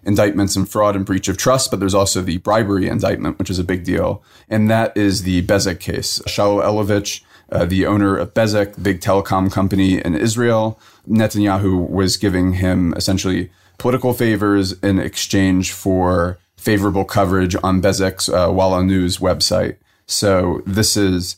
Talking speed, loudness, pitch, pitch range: 160 wpm, -17 LUFS, 95 Hz, 95-105 Hz